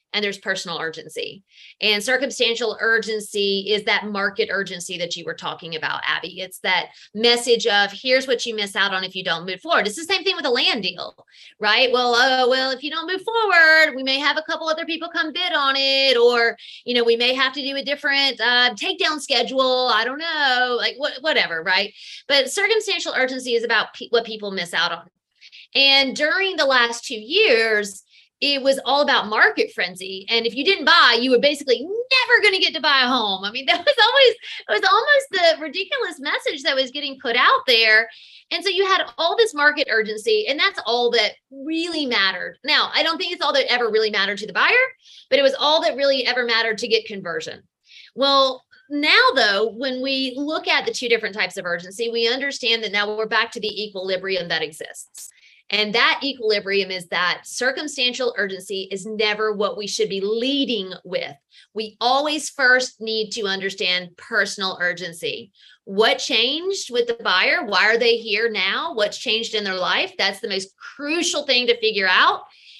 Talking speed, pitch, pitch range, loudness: 200 wpm, 245 Hz, 210-295 Hz, -19 LUFS